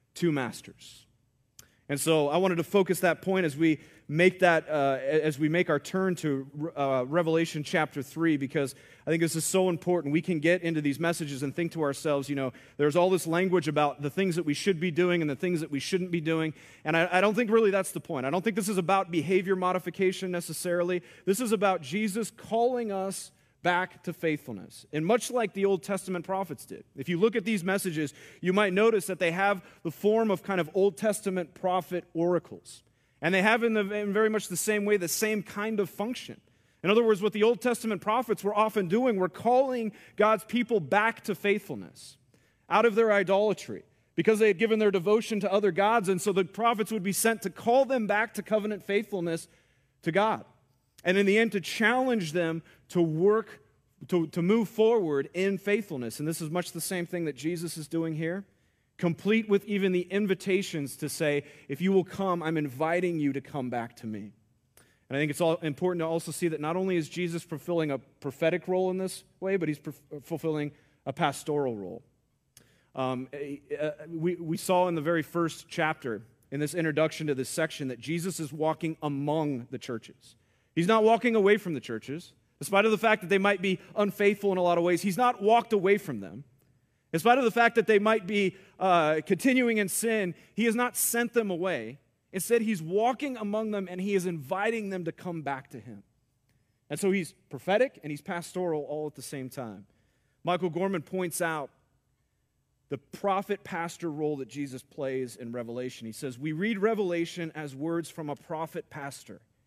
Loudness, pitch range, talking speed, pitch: -28 LUFS, 145-200 Hz, 205 wpm, 175 Hz